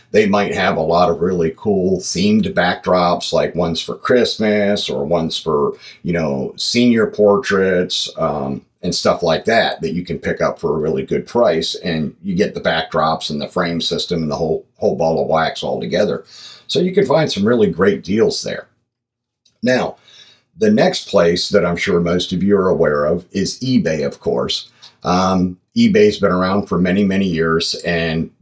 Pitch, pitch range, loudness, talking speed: 95 Hz, 85-120 Hz, -17 LUFS, 190 wpm